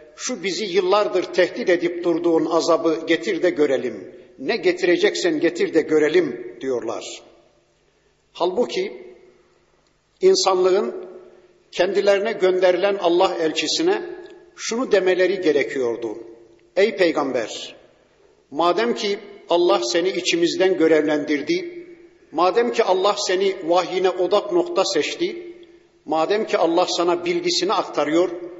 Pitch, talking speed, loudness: 190 Hz, 100 wpm, -20 LUFS